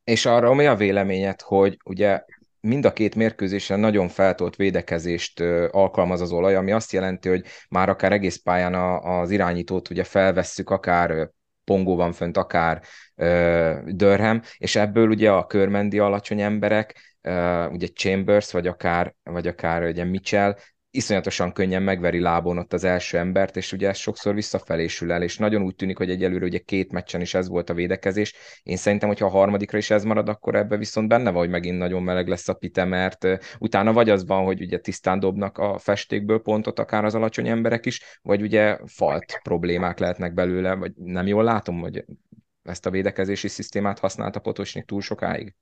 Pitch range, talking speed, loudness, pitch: 90-105 Hz, 175 wpm, -22 LUFS, 95 Hz